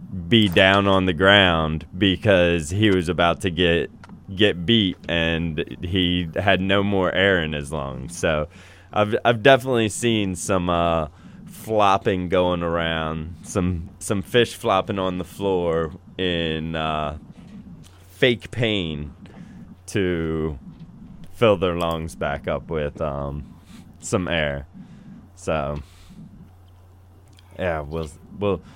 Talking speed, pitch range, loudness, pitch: 120 wpm, 80-95 Hz, -21 LUFS, 90 Hz